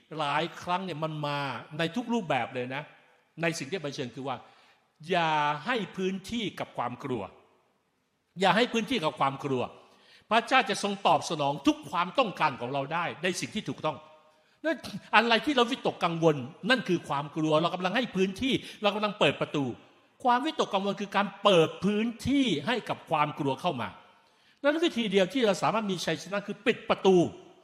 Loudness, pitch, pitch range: -28 LUFS, 185 Hz, 155-225 Hz